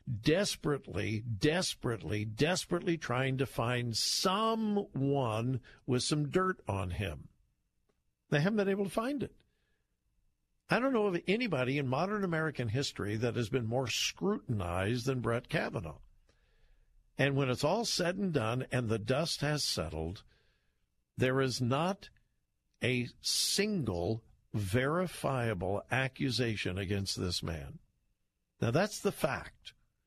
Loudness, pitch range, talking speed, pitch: -33 LUFS, 110-160 Hz, 125 wpm, 130 Hz